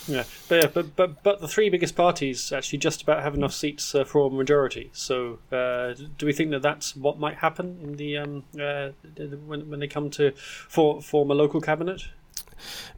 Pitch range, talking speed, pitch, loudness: 140-160 Hz, 215 wpm, 145 Hz, -25 LUFS